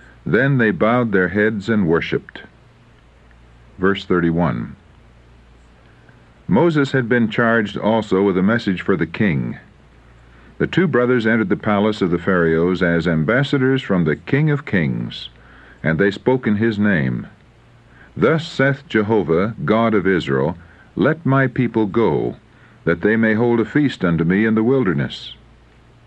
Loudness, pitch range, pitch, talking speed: -18 LUFS, 85-120 Hz, 105 Hz, 145 wpm